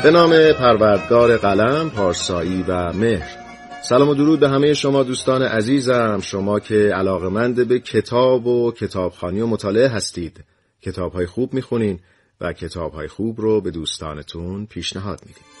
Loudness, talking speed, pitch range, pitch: -18 LUFS, 140 wpm, 90-125 Hz, 110 Hz